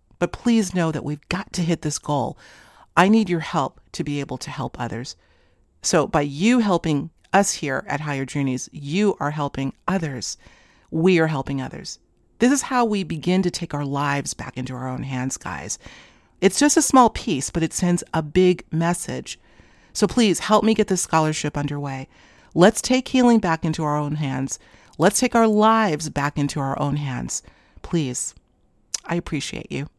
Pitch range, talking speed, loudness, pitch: 135-185 Hz, 185 wpm, -22 LUFS, 155 Hz